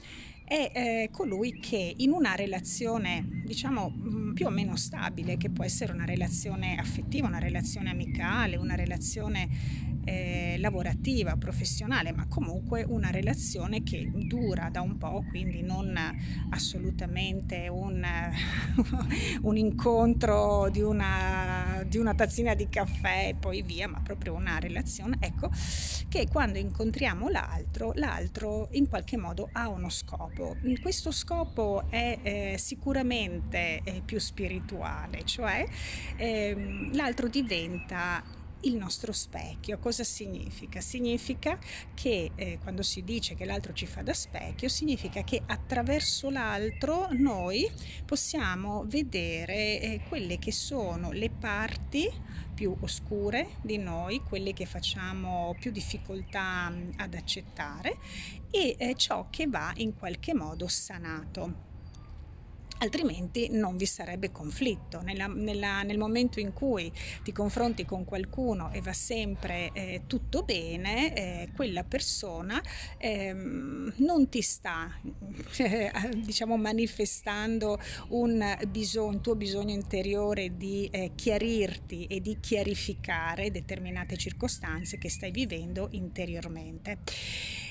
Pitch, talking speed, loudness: 200 Hz, 120 wpm, -32 LUFS